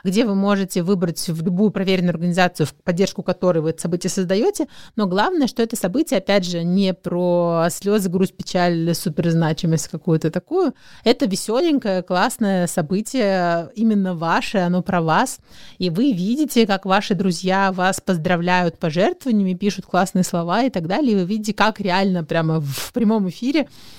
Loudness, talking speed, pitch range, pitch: -20 LUFS, 160 wpm, 175-210 Hz, 190 Hz